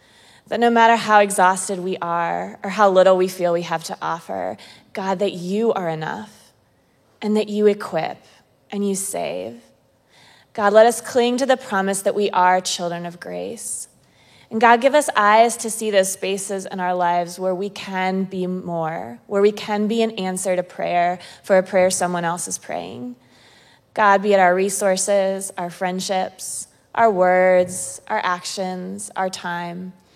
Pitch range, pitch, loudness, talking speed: 180-210 Hz, 190 Hz, -20 LUFS, 170 wpm